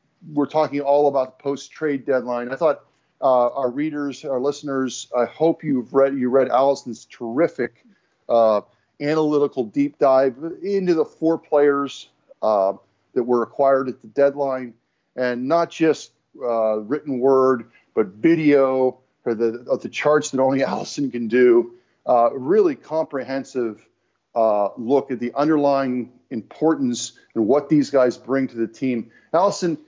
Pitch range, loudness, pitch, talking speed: 125-150 Hz, -21 LUFS, 135 Hz, 150 wpm